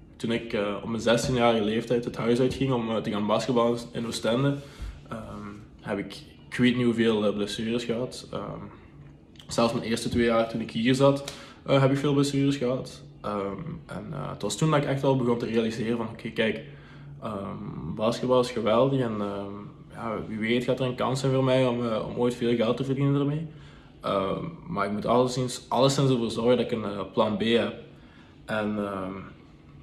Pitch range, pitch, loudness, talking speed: 110-130 Hz, 120 Hz, -26 LUFS, 205 wpm